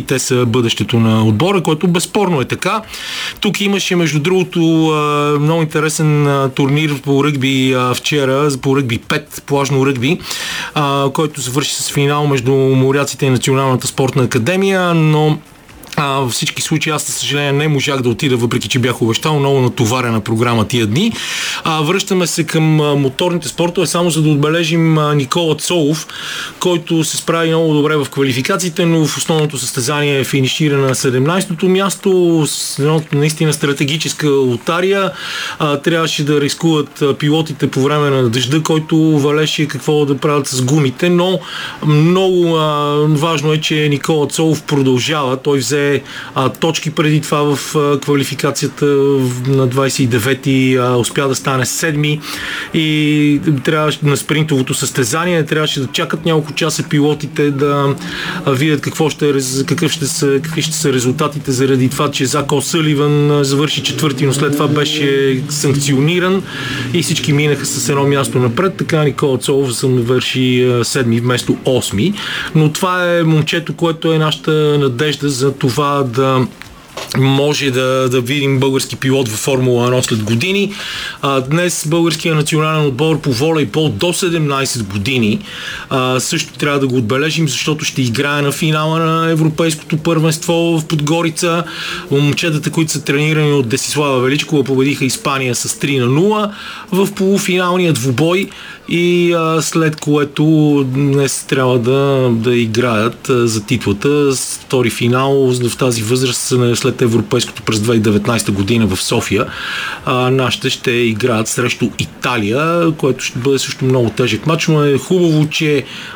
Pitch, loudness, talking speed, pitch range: 145 Hz, -14 LUFS, 145 wpm, 130-160 Hz